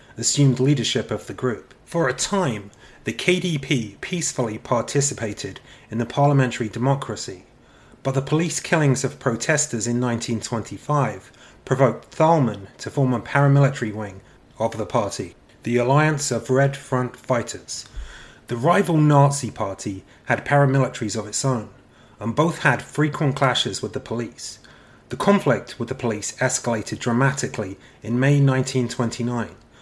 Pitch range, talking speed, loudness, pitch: 115-140 Hz, 135 wpm, -22 LUFS, 125 Hz